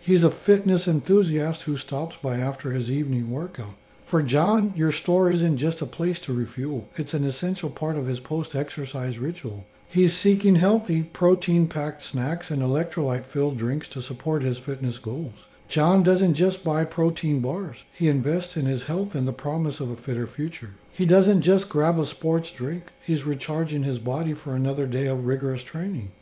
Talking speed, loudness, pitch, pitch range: 175 wpm, -24 LUFS, 150 Hz, 130-170 Hz